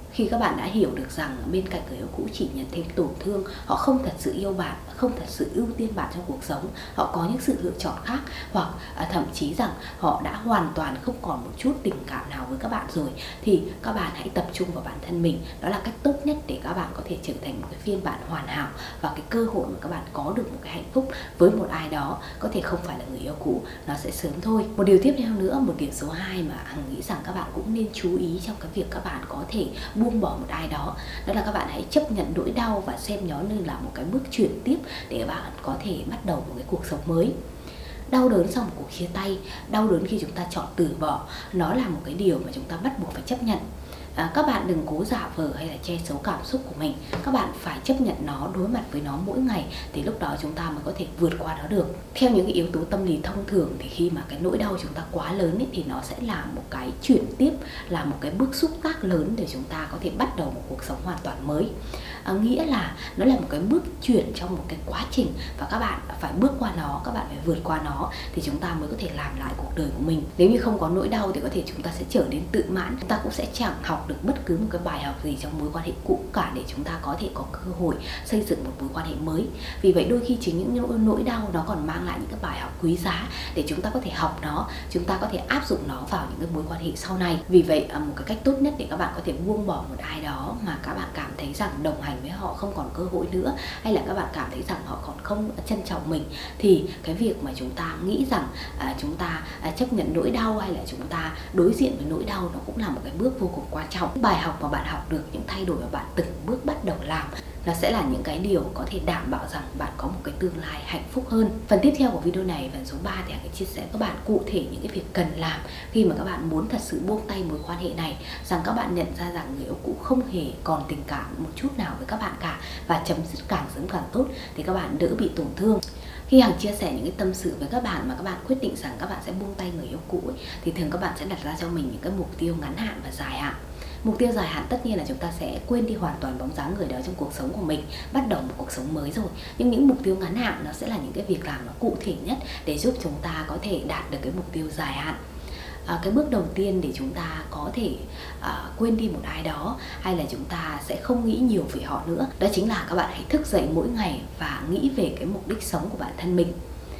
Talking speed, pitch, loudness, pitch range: 290 wpm, 190 Hz, -27 LUFS, 165-235 Hz